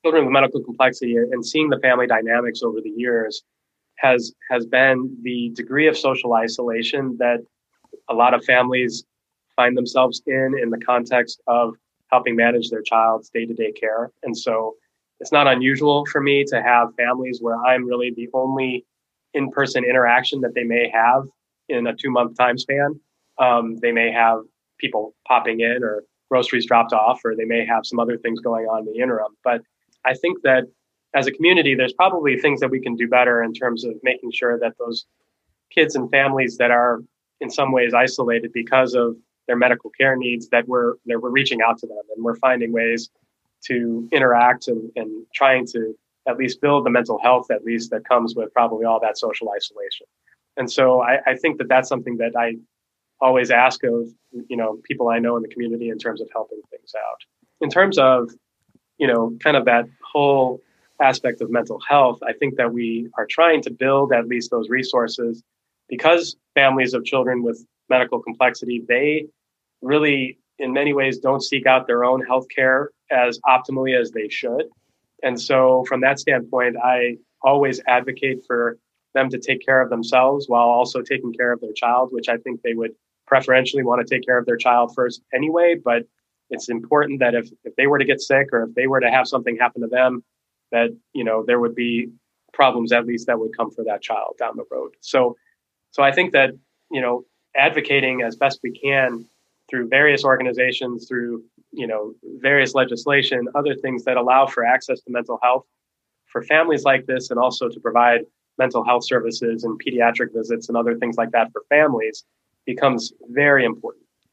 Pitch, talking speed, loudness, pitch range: 125 Hz, 195 wpm, -19 LUFS, 120-135 Hz